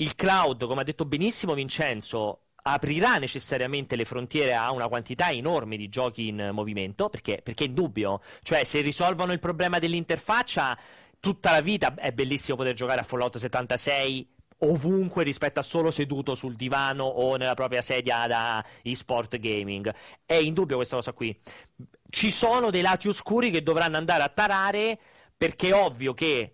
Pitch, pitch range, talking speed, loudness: 140 Hz, 125-170 Hz, 165 wpm, -26 LUFS